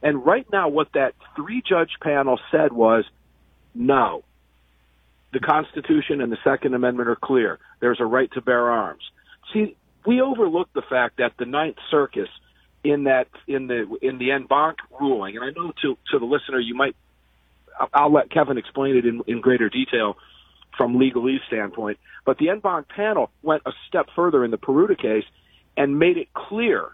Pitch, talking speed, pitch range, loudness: 130 Hz, 180 wpm, 110-150 Hz, -22 LUFS